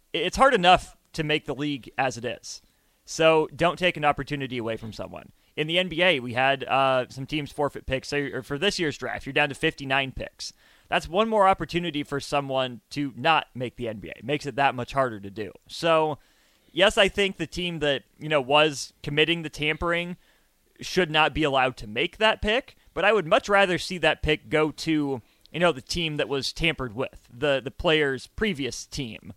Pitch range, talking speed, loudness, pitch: 130-165 Hz, 205 wpm, -25 LUFS, 145 Hz